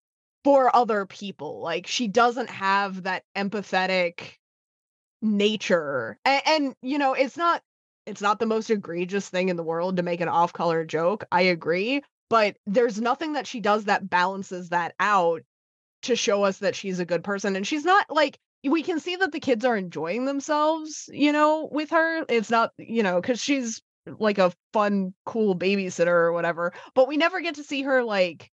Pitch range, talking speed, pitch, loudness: 185-270 Hz, 185 wpm, 215 Hz, -24 LUFS